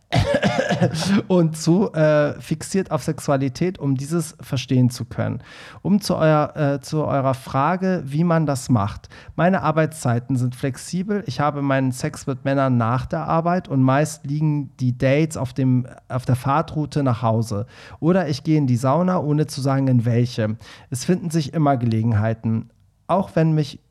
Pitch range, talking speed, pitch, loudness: 125-160 Hz, 165 wpm, 140 Hz, -21 LUFS